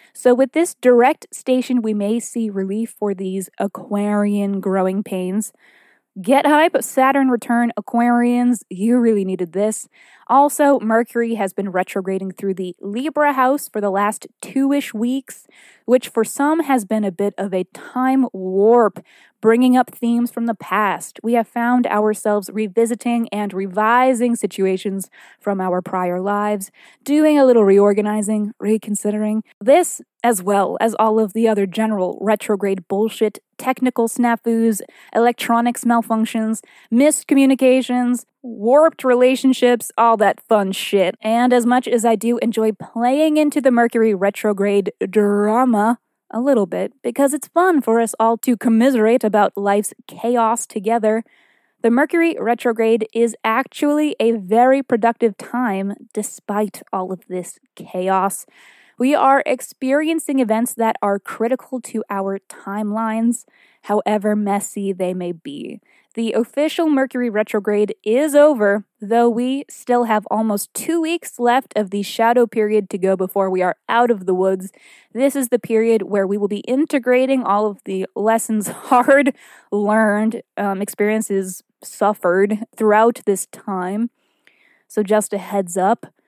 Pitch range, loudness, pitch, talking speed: 205-250 Hz, -18 LUFS, 225 Hz, 140 wpm